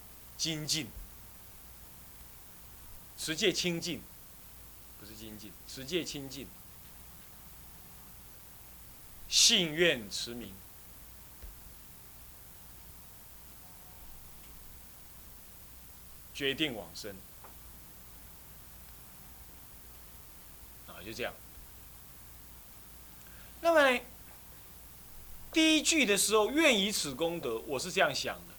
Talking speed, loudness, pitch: 95 characters per minute, -30 LUFS, 110 Hz